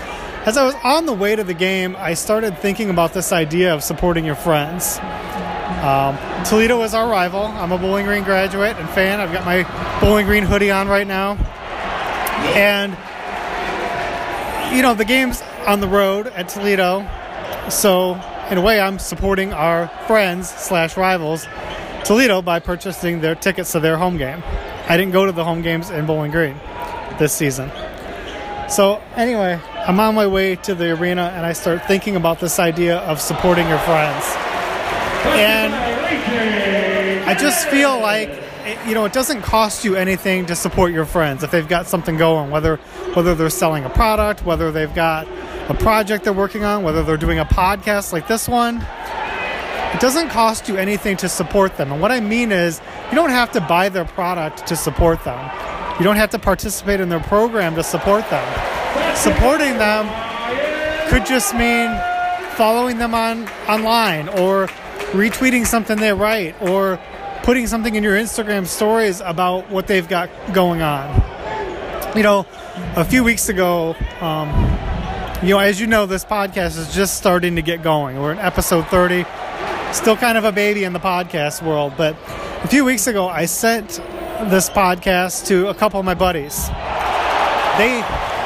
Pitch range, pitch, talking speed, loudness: 170-215 Hz, 190 Hz, 175 wpm, -17 LUFS